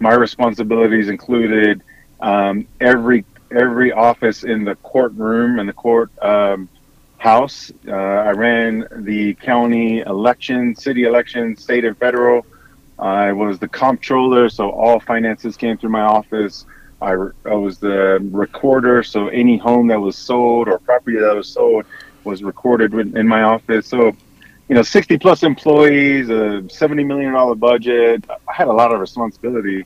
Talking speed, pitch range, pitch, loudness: 150 wpm, 105-120 Hz, 115 Hz, -15 LUFS